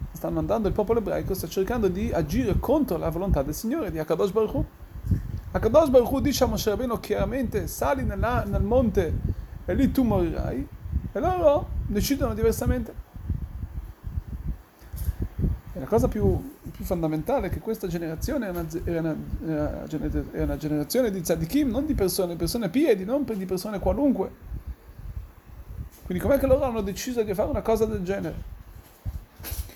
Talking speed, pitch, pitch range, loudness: 155 wpm, 190 Hz, 150-235 Hz, -26 LUFS